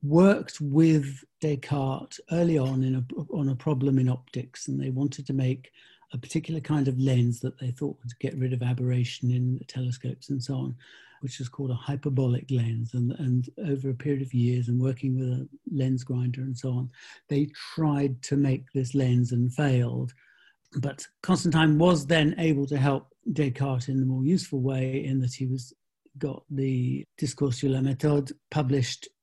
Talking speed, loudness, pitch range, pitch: 185 wpm, -27 LUFS, 125-145 Hz, 135 Hz